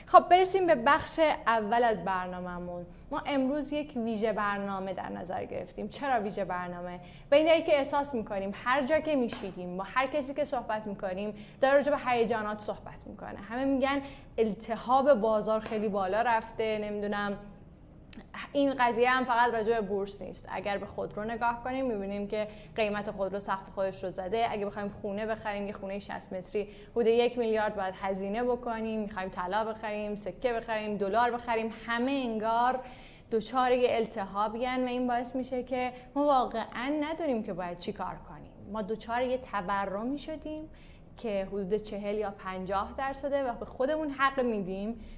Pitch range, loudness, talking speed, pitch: 200-255 Hz, -31 LUFS, 165 wpm, 225 Hz